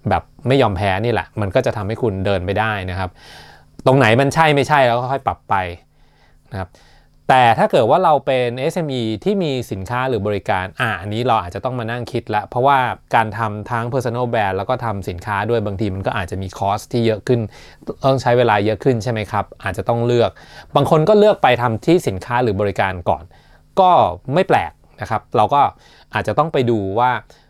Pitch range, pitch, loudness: 100-125 Hz, 115 Hz, -17 LUFS